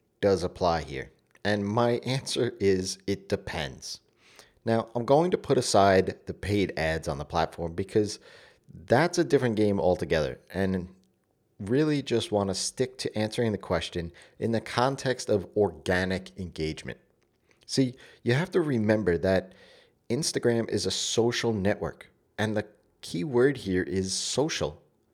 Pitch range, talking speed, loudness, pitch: 95-115 Hz, 145 wpm, -27 LUFS, 105 Hz